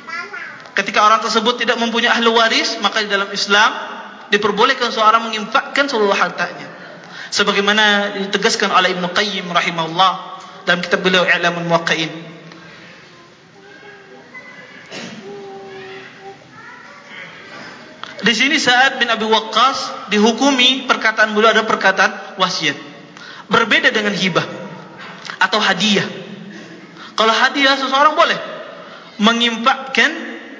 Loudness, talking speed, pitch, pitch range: -14 LUFS, 95 wpm, 210 Hz, 185-235 Hz